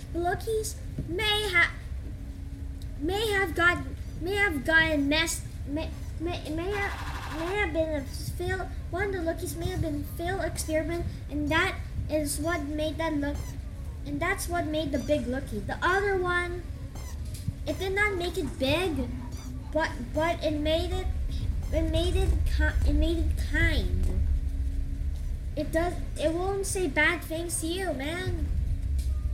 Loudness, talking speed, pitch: -29 LUFS, 155 wpm, 315 Hz